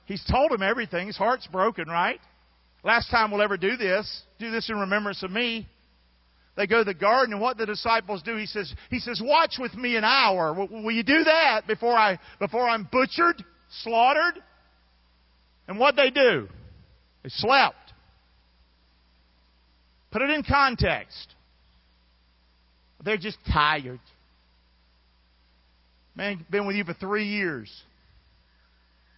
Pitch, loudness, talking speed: 190 Hz, -24 LUFS, 145 wpm